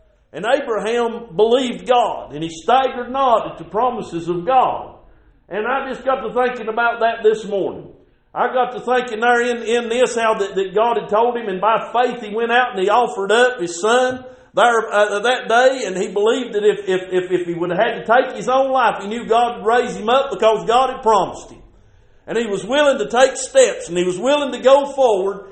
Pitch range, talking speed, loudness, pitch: 210-250 Hz, 230 wpm, -17 LUFS, 235 Hz